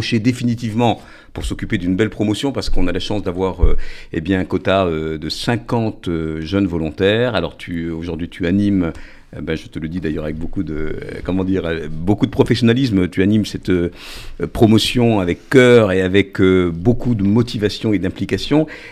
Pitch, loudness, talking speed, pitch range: 95 Hz, -18 LUFS, 180 wpm, 85-110 Hz